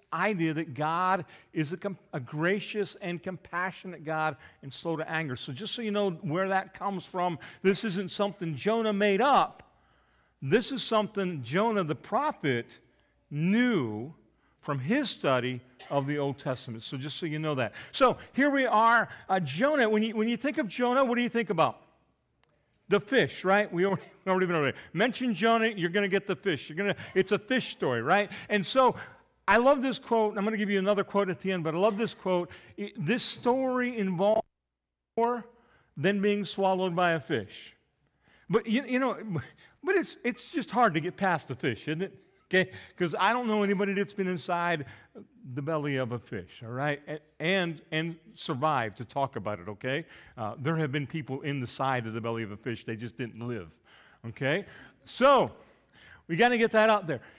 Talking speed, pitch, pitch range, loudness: 195 wpm, 185 Hz, 150-215 Hz, -29 LUFS